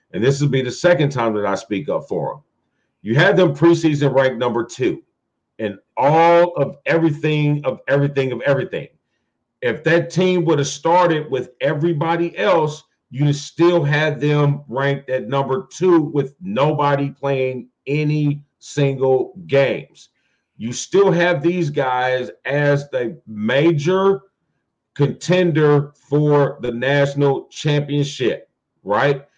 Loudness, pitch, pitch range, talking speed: -18 LUFS, 145 Hz, 140-170 Hz, 135 wpm